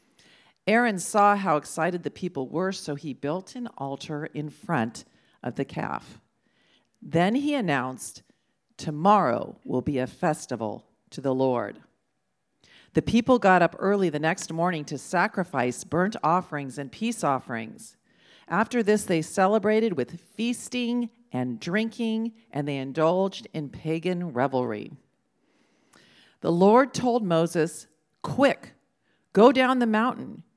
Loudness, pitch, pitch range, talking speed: -25 LUFS, 175 Hz, 145-215 Hz, 130 wpm